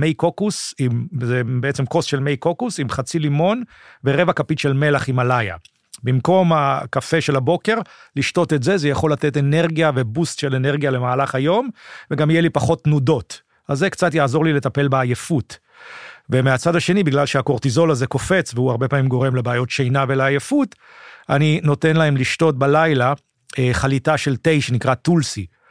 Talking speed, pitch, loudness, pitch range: 160 wpm, 145 Hz, -18 LUFS, 130-160 Hz